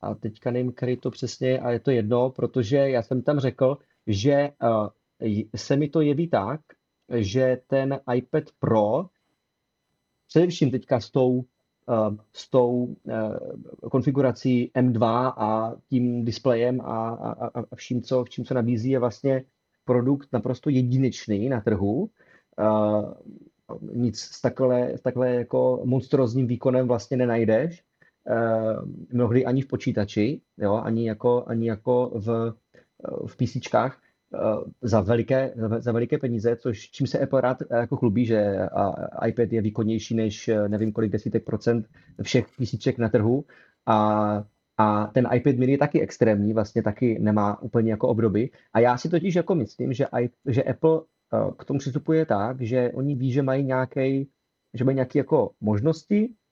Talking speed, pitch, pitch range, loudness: 150 wpm, 125 Hz, 115-130 Hz, -24 LUFS